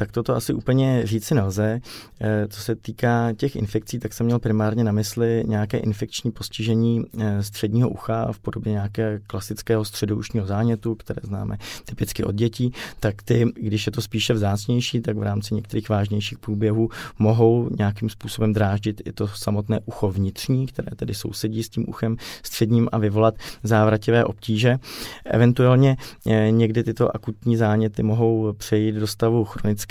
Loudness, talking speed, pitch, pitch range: -23 LUFS, 155 wpm, 110 Hz, 105-115 Hz